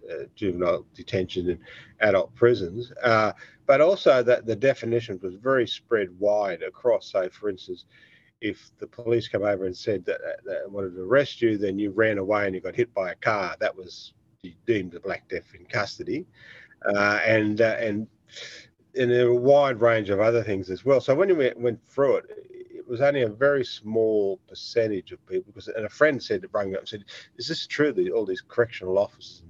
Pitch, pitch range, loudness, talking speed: 120 Hz, 105-145 Hz, -25 LUFS, 210 wpm